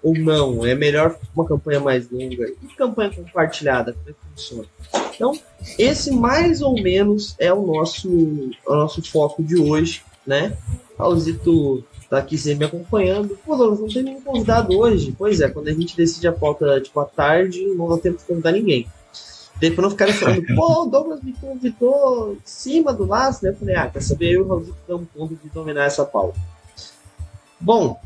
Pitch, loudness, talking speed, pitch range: 165 Hz, -19 LUFS, 185 wpm, 140-210 Hz